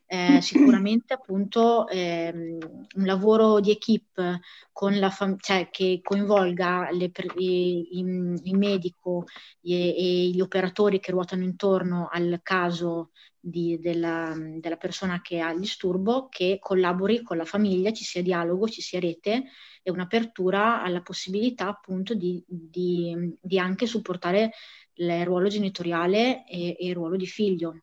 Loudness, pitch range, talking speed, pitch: -25 LUFS, 175-200 Hz, 135 wpm, 185 Hz